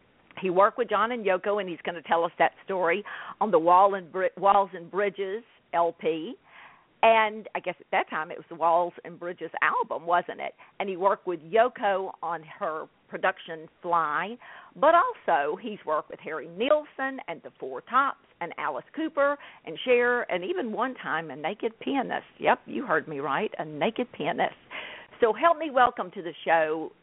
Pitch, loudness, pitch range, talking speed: 195 Hz, -27 LUFS, 170-240 Hz, 190 wpm